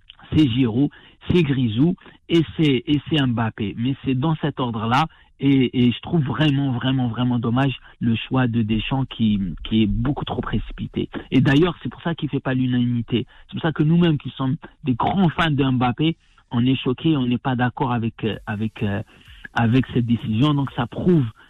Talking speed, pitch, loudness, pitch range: 195 wpm, 130 Hz, -21 LUFS, 120-150 Hz